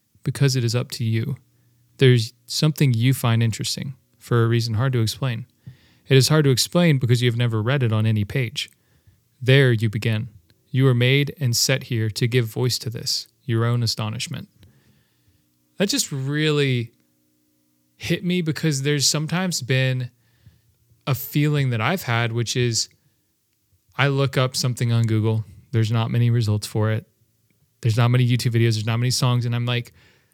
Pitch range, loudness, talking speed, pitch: 115-135 Hz, -21 LUFS, 170 wpm, 120 Hz